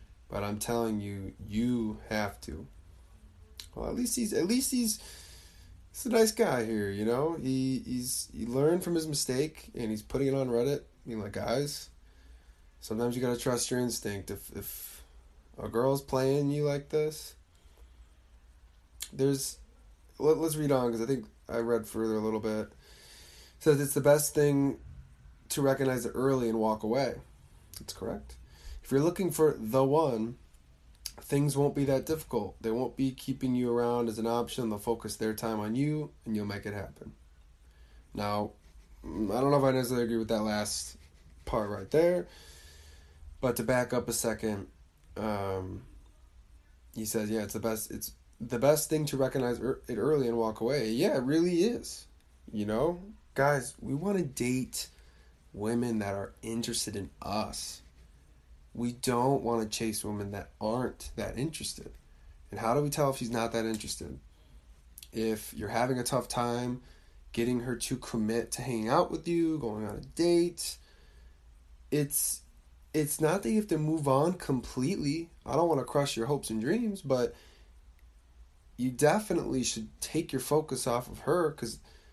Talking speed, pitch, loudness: 175 wpm, 110 Hz, -31 LUFS